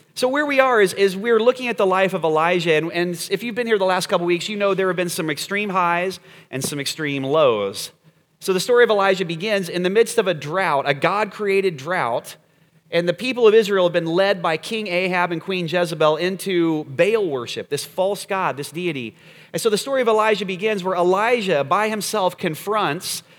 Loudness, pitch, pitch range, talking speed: -20 LUFS, 185 Hz, 170-210 Hz, 220 wpm